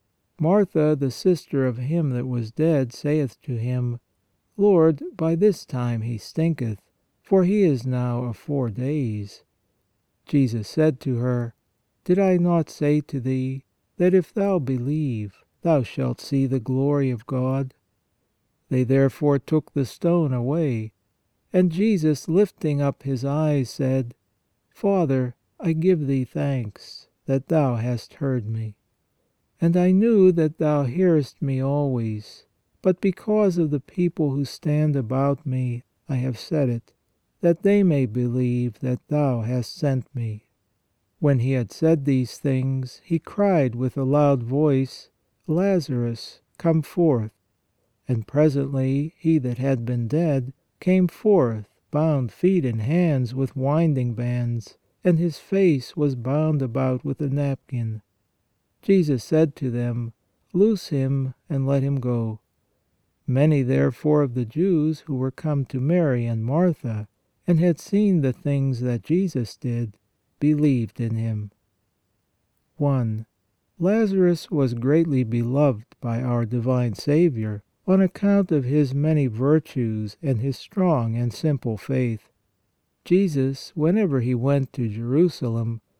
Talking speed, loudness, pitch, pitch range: 140 wpm, -23 LUFS, 135 Hz, 120-155 Hz